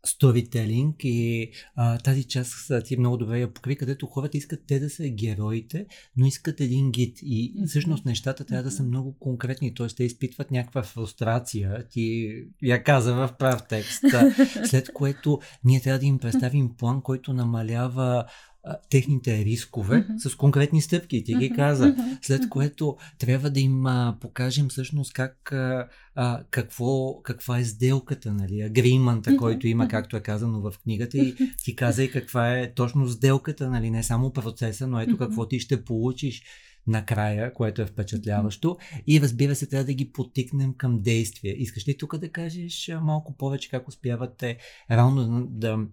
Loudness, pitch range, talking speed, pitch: -25 LUFS, 120-140 Hz, 160 wpm, 130 Hz